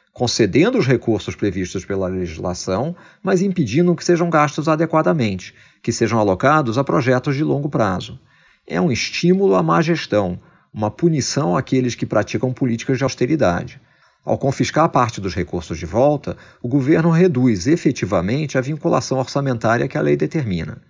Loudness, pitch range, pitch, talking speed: -18 LUFS, 105-155 Hz, 130 Hz, 150 wpm